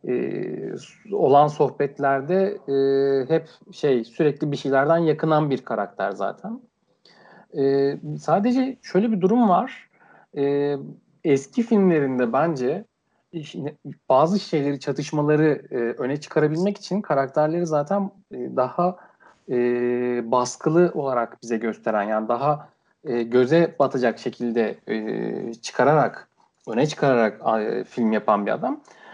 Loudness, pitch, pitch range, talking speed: -22 LUFS, 145 Hz, 130-170 Hz, 110 wpm